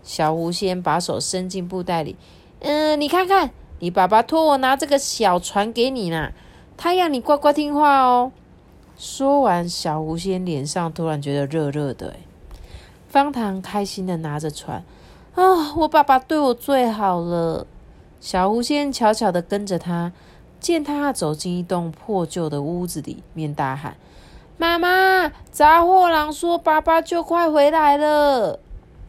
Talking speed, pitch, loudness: 215 characters per minute, 215 Hz, -19 LUFS